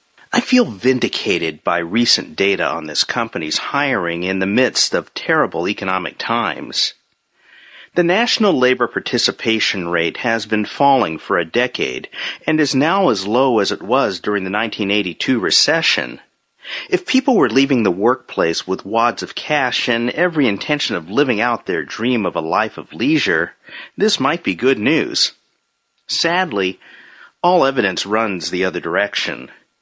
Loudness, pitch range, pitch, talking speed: -17 LUFS, 95-150 Hz, 115 Hz, 150 wpm